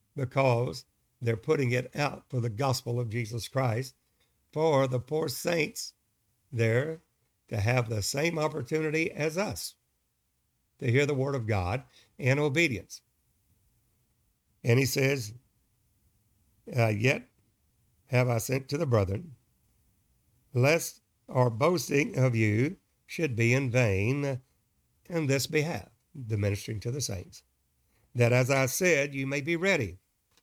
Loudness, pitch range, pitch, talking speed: -29 LUFS, 115-140 Hz, 125 Hz, 130 wpm